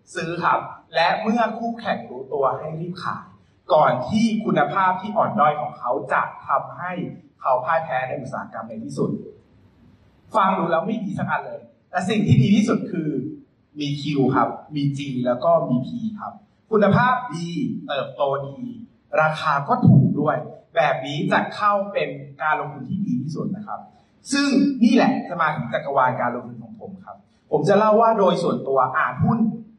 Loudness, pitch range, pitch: -21 LUFS, 145-220 Hz, 185 Hz